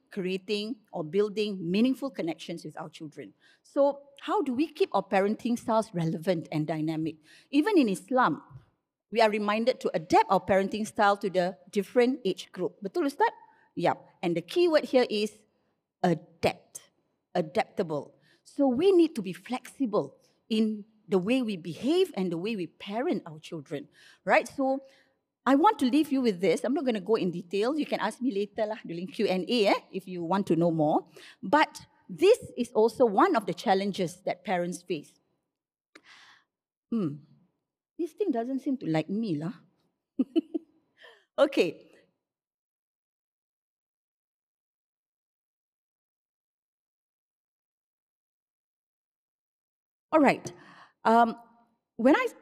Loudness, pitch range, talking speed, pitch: -28 LUFS, 180-265 Hz, 140 wpm, 215 Hz